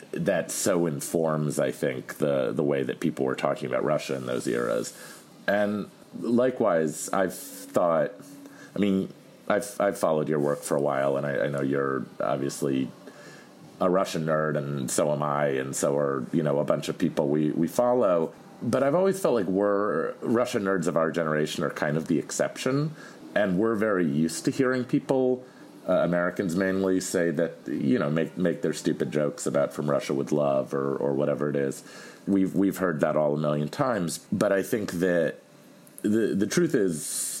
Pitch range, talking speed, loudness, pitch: 75-100 Hz, 190 wpm, -26 LUFS, 85 Hz